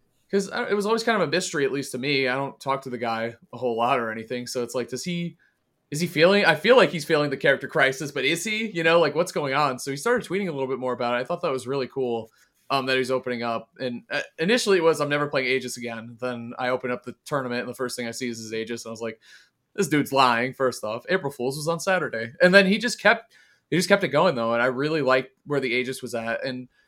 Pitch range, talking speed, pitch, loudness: 125-170 Hz, 290 wpm, 135 Hz, -24 LUFS